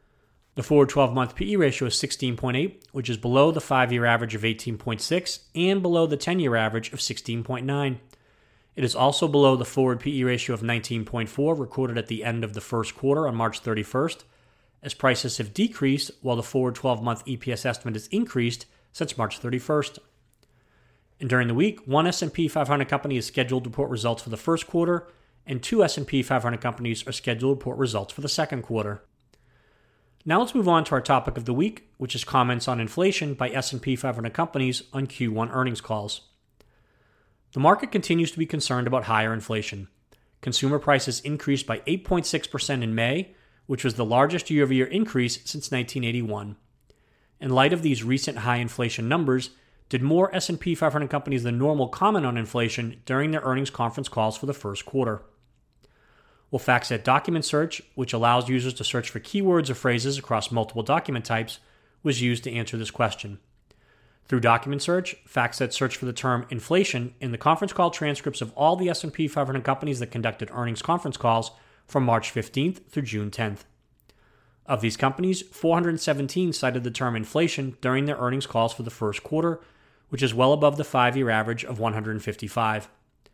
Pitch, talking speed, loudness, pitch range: 130 Hz, 175 wpm, -25 LUFS, 115-145 Hz